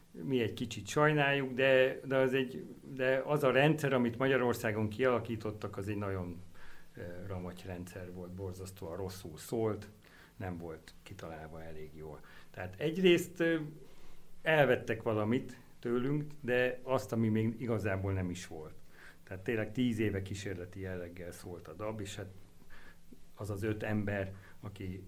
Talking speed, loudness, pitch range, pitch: 140 wpm, -34 LUFS, 90-125 Hz, 105 Hz